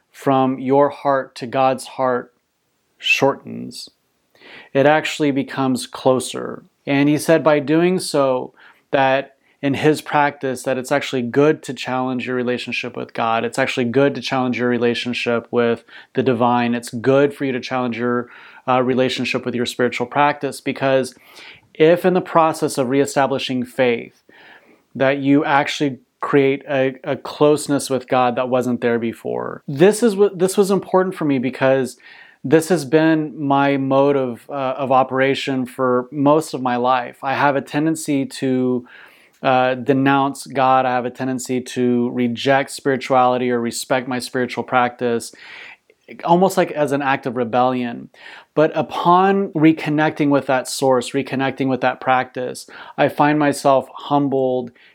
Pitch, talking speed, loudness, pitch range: 135 Hz, 150 wpm, -18 LUFS, 125-145 Hz